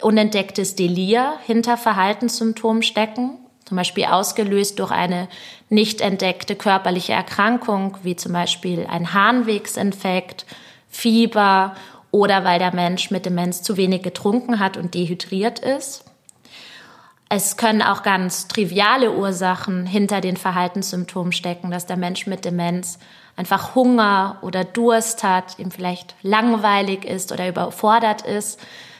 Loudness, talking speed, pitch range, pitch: -19 LUFS, 125 wpm, 180-220 Hz, 195 Hz